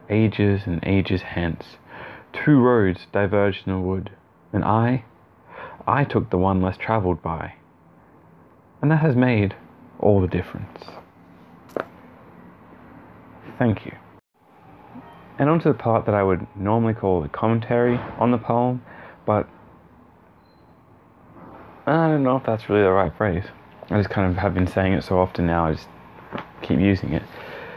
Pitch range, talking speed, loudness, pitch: 95-120 Hz, 150 wpm, -22 LUFS, 100 Hz